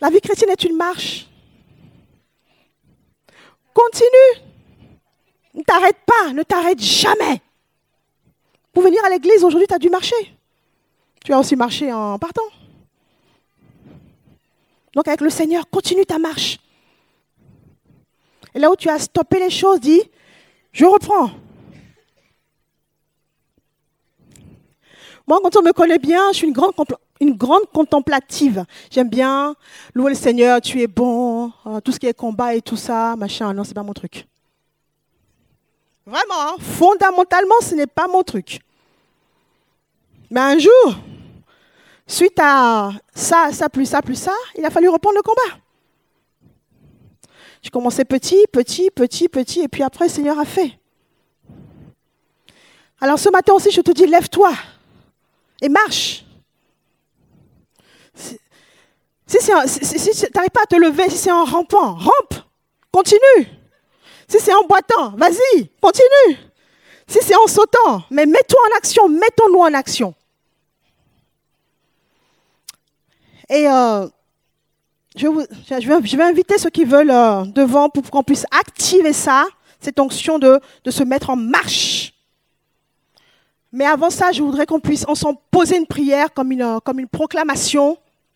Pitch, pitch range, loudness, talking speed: 320 Hz, 270-375 Hz, -14 LUFS, 140 wpm